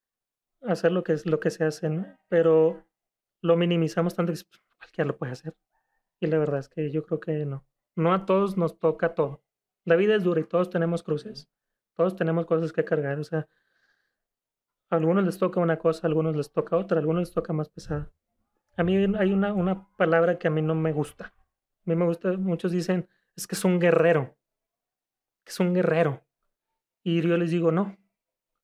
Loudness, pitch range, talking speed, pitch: -26 LUFS, 160-180 Hz, 205 wpm, 170 Hz